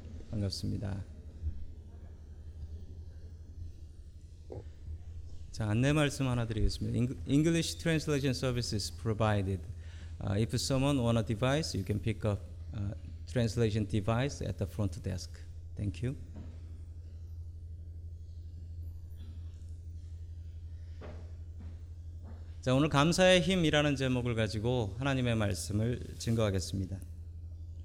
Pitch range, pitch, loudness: 85-115 Hz, 85 Hz, -32 LUFS